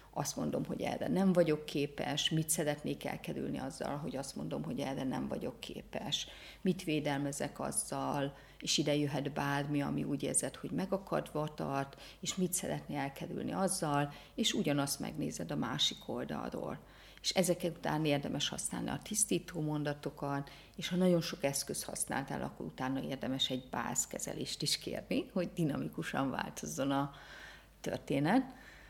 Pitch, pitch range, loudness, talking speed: 150 Hz, 140-175 Hz, -36 LUFS, 140 wpm